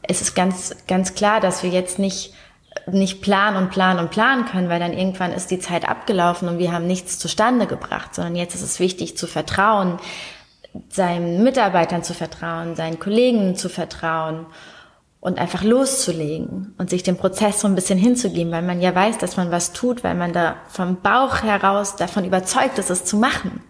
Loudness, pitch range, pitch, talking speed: -20 LUFS, 175-205 Hz, 185 Hz, 190 wpm